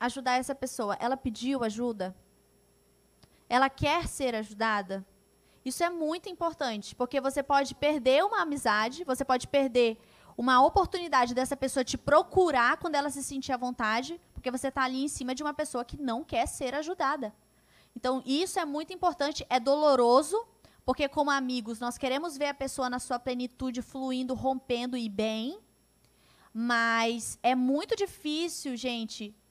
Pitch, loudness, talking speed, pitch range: 260 Hz, -29 LUFS, 155 wpm, 245-290 Hz